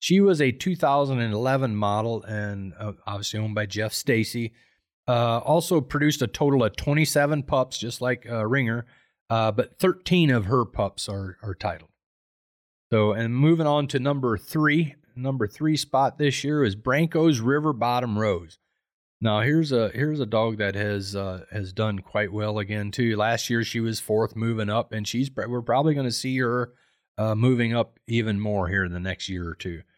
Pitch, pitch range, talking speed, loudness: 115 Hz, 105-140 Hz, 185 wpm, -24 LUFS